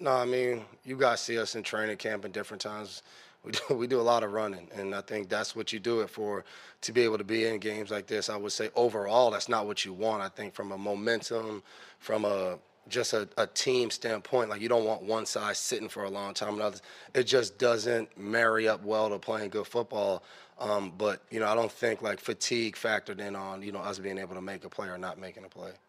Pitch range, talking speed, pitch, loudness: 100-115 Hz, 250 wpm, 110 Hz, -31 LUFS